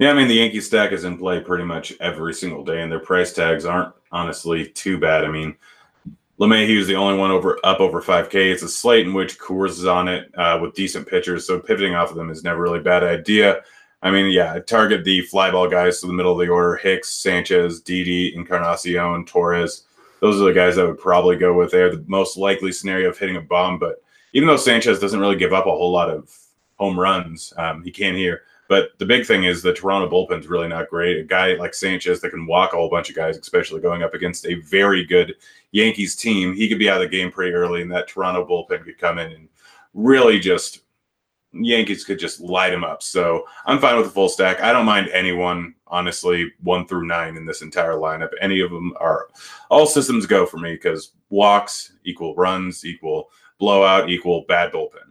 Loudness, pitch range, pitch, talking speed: -18 LUFS, 85-100 Hz, 90 Hz, 225 wpm